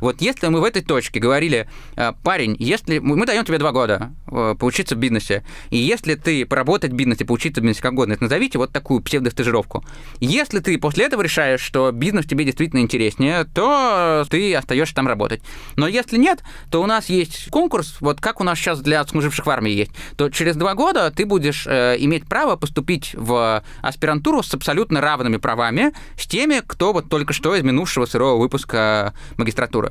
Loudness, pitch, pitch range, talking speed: -19 LUFS, 150 Hz, 125-175 Hz, 185 wpm